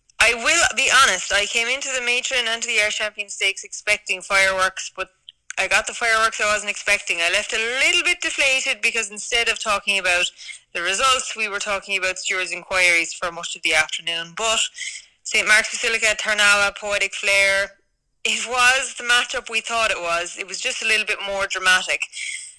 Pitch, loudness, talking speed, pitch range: 210 Hz, -19 LUFS, 190 wpm, 195-235 Hz